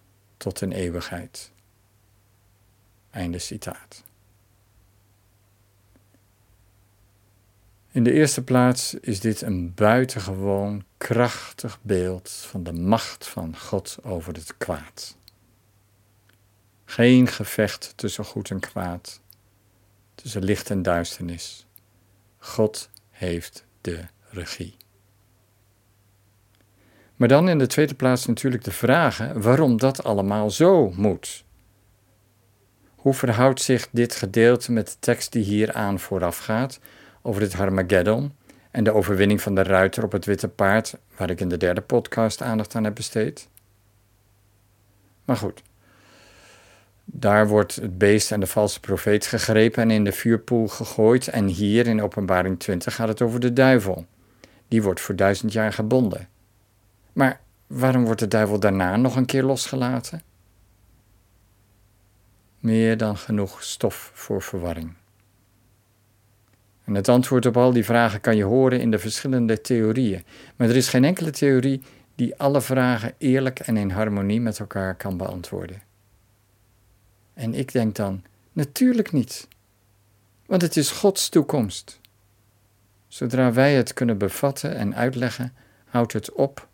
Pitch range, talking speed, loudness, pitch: 100-120 Hz, 130 wpm, -22 LUFS, 105 Hz